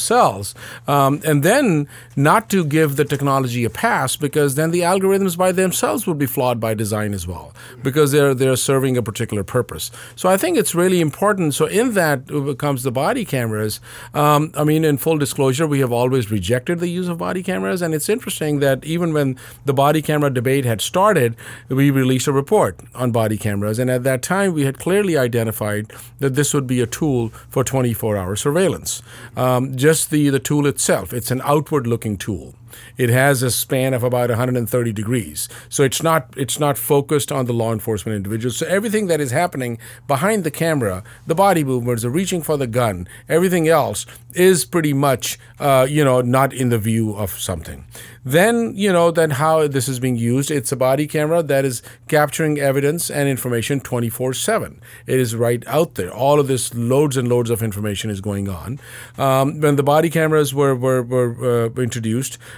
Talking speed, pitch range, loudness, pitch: 195 wpm, 120-150 Hz, -18 LUFS, 135 Hz